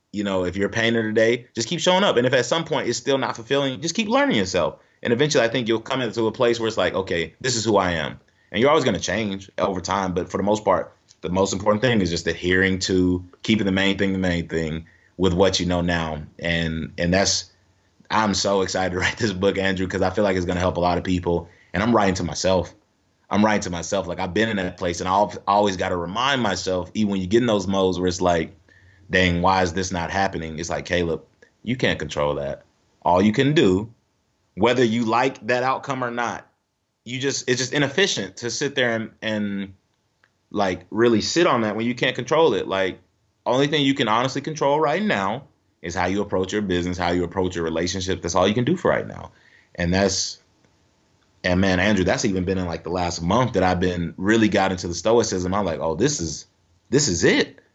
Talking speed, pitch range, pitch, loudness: 240 wpm, 90-110 Hz, 95 Hz, -22 LUFS